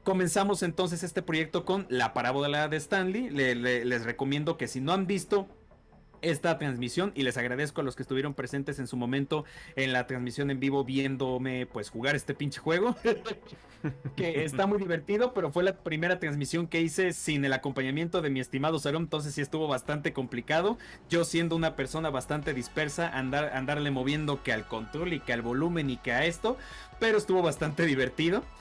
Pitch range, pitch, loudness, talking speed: 130-170 Hz, 150 Hz, -30 LUFS, 185 wpm